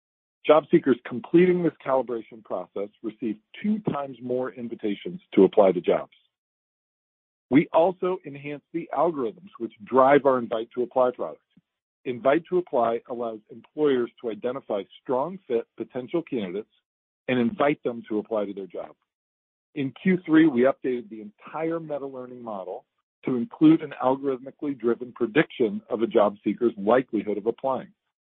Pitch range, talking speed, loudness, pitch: 115-155 Hz, 145 wpm, -25 LUFS, 130 Hz